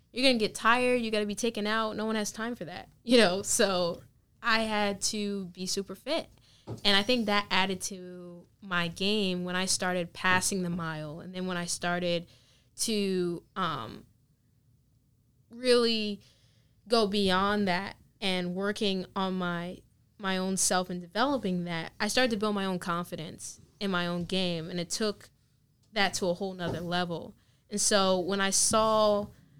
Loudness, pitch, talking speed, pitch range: -29 LUFS, 185 Hz, 170 wpm, 175-210 Hz